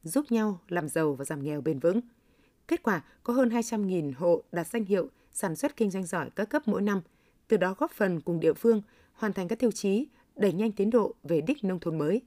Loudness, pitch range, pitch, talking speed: -29 LUFS, 170-230 Hz, 205 Hz, 235 wpm